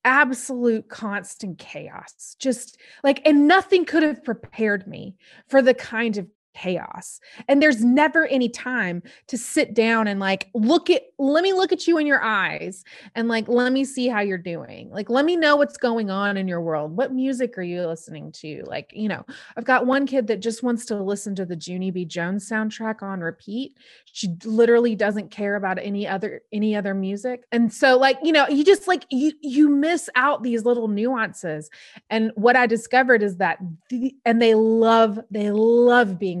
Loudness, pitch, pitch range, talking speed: -21 LUFS, 230 Hz, 205-265 Hz, 195 wpm